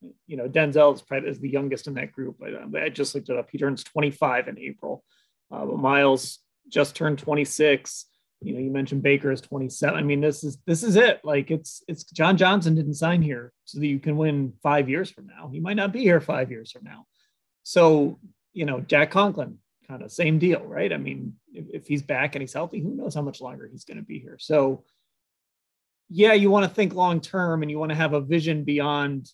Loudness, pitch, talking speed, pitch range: -23 LUFS, 150 Hz, 235 wpm, 140-165 Hz